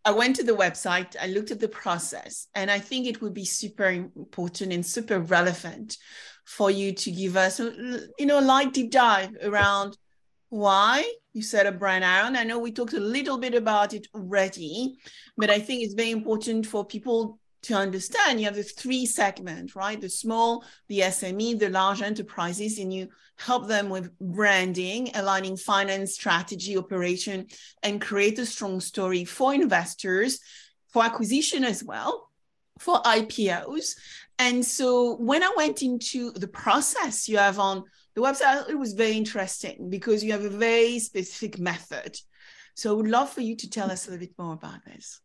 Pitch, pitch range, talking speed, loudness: 210 Hz, 190-235 Hz, 180 wpm, -25 LUFS